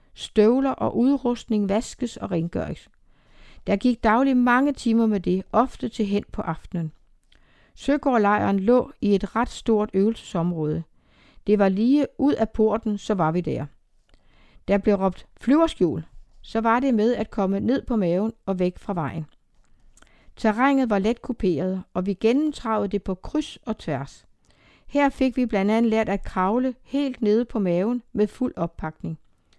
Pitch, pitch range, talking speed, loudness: 215 Hz, 190-245 Hz, 160 wpm, -23 LUFS